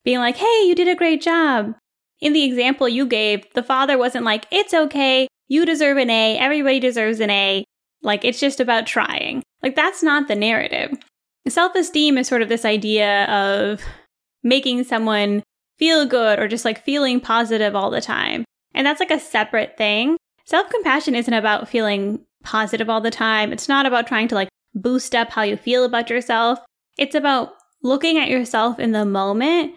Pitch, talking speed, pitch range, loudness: 250 Hz, 185 wpm, 220-285 Hz, -18 LUFS